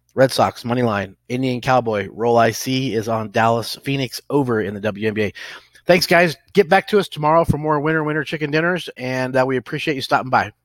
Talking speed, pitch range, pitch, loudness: 205 wpm, 115-155 Hz, 130 Hz, -19 LUFS